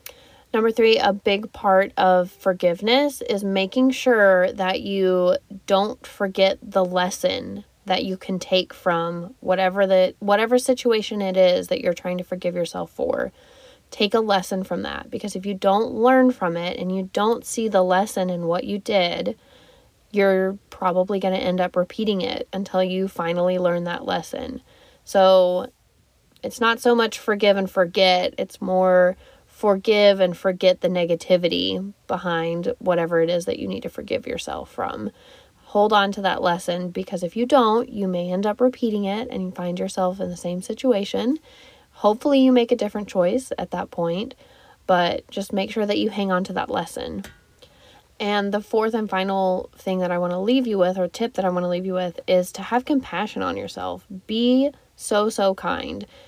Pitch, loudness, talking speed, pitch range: 195 Hz, -21 LUFS, 180 wpm, 180-230 Hz